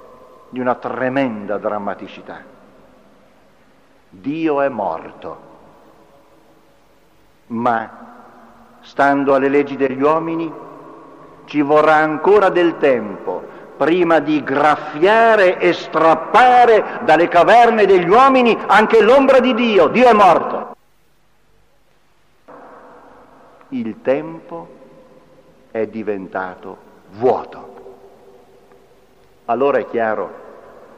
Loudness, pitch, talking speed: -14 LUFS, 160 Hz, 80 wpm